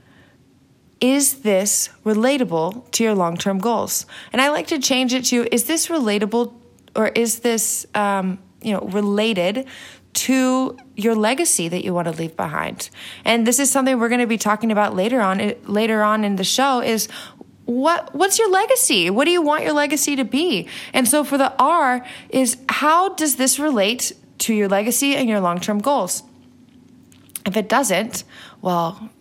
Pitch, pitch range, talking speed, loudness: 235 Hz, 205-265 Hz, 175 wpm, -19 LUFS